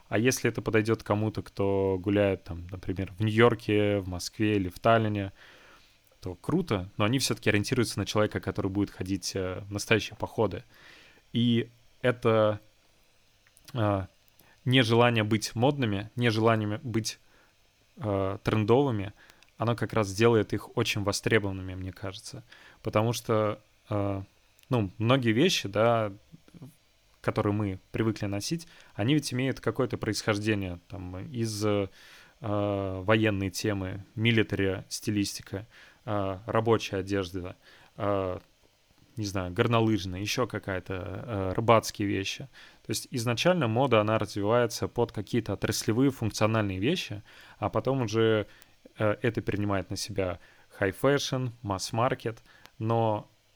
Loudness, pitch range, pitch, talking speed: -28 LUFS, 100-115 Hz, 105 Hz, 120 wpm